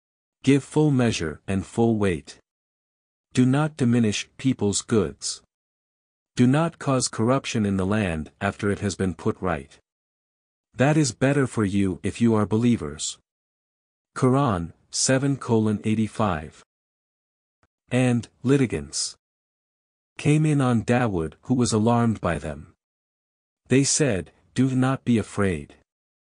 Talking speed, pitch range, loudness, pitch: 125 wpm, 85-125 Hz, -23 LUFS, 110 Hz